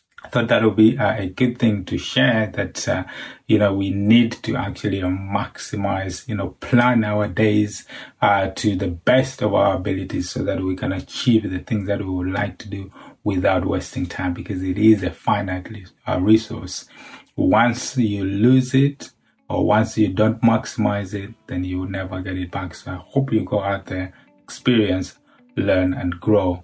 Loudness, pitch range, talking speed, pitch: -20 LUFS, 95-110 Hz, 180 wpm, 105 Hz